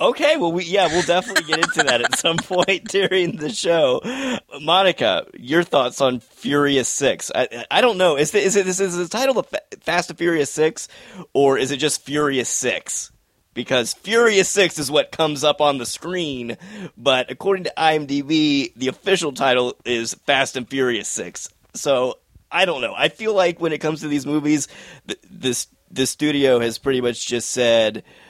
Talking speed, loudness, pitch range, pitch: 185 wpm, -19 LUFS, 130-180 Hz, 150 Hz